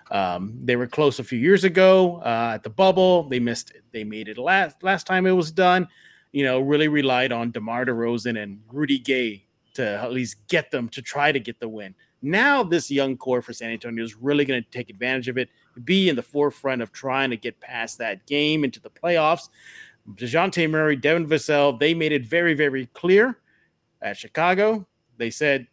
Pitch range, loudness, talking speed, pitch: 120-165 Hz, -22 LUFS, 205 wpm, 135 Hz